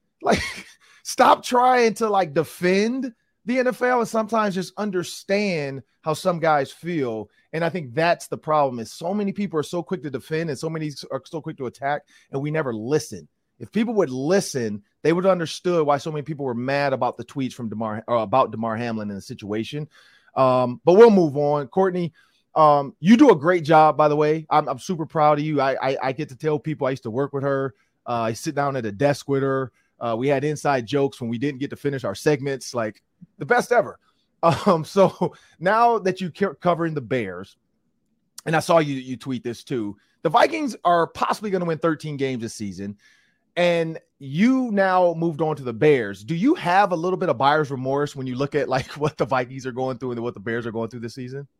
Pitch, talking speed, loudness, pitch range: 150 Hz, 225 wpm, -22 LUFS, 130-175 Hz